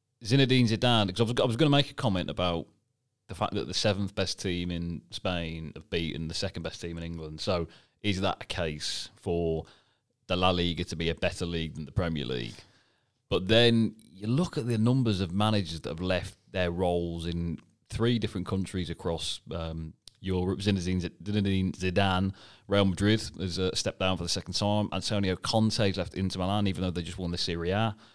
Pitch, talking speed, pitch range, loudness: 95 Hz, 195 wpm, 85-105 Hz, -29 LUFS